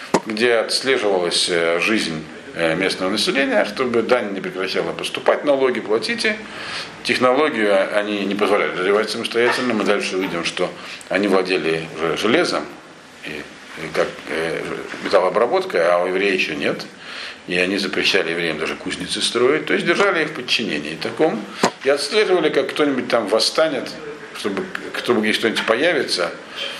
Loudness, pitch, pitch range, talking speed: -19 LUFS, 100 Hz, 85-130 Hz, 130 wpm